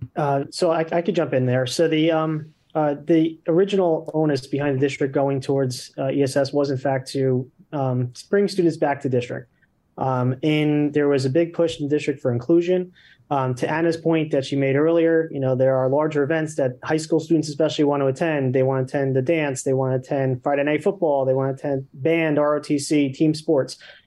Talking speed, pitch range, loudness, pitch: 215 wpm, 135-160 Hz, -21 LUFS, 145 Hz